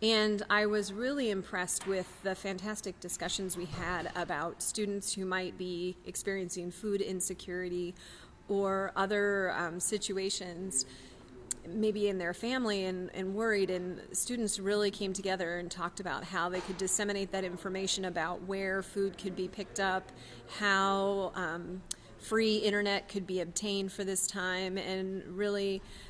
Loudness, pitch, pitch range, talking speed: -33 LUFS, 190 Hz, 180-200 Hz, 145 wpm